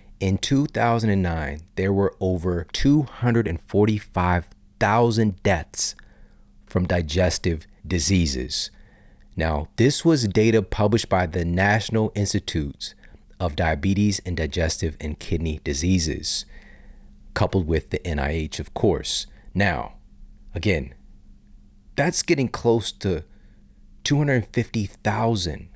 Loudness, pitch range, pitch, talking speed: -23 LUFS, 85-105 Hz, 95 Hz, 90 wpm